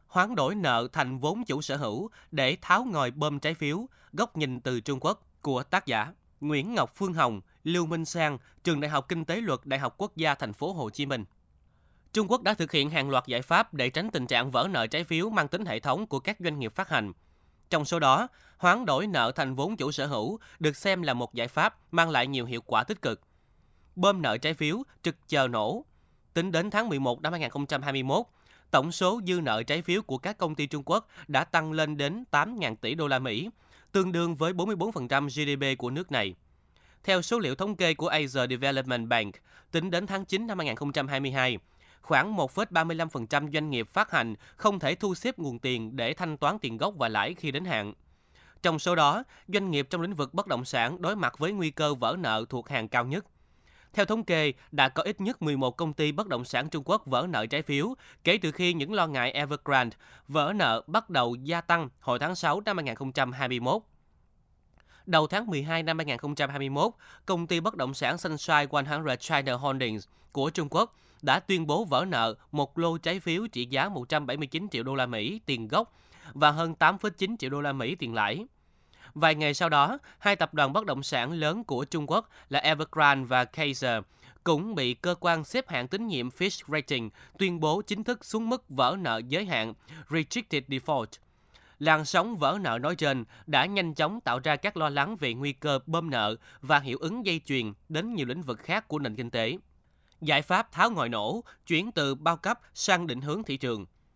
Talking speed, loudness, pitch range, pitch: 210 wpm, -28 LUFS, 130-170 Hz, 150 Hz